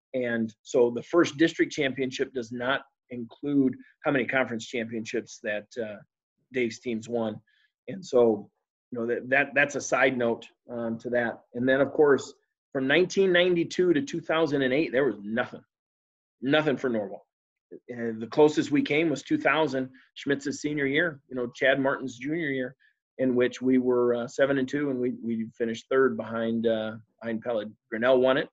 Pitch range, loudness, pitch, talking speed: 115-145 Hz, -27 LUFS, 130 Hz, 170 wpm